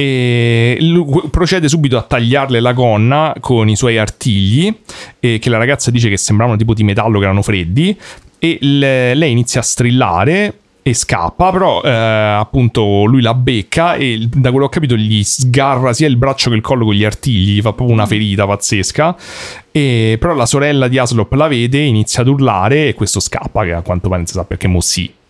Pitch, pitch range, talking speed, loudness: 120 Hz, 110-140 Hz, 200 wpm, -12 LUFS